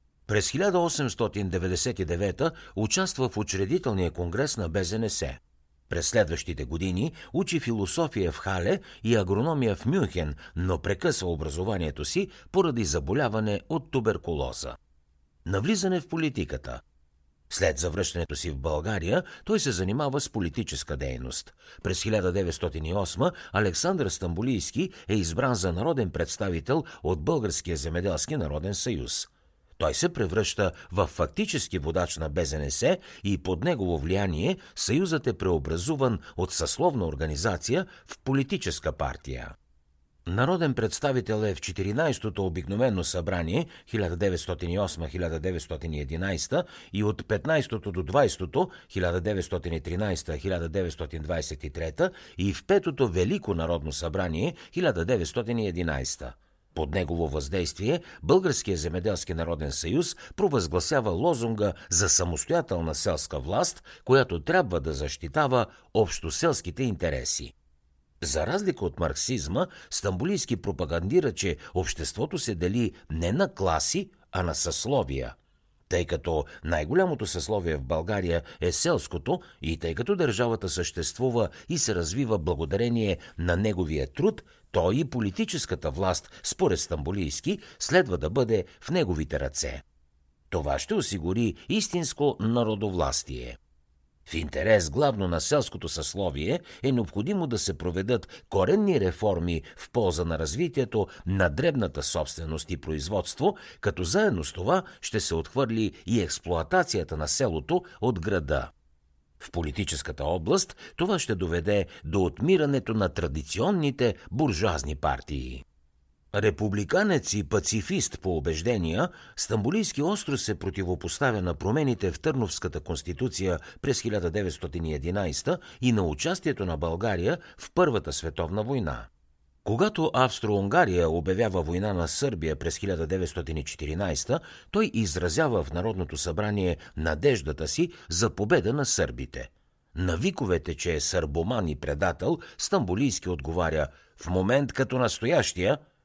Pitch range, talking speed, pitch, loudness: 80-115 Hz, 110 wpm, 95 Hz, -27 LUFS